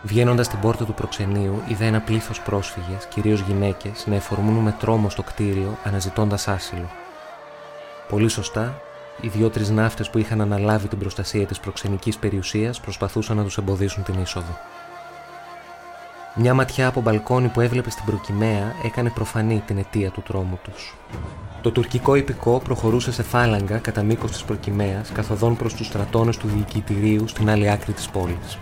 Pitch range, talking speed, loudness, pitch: 100-115 Hz, 155 wpm, -22 LUFS, 110 Hz